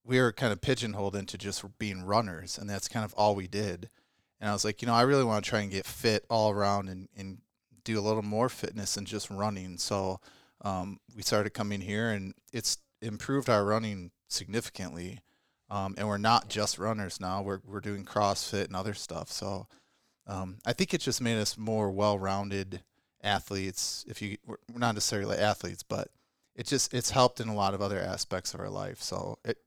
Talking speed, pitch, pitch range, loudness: 205 wpm, 105 Hz, 100-110 Hz, -31 LUFS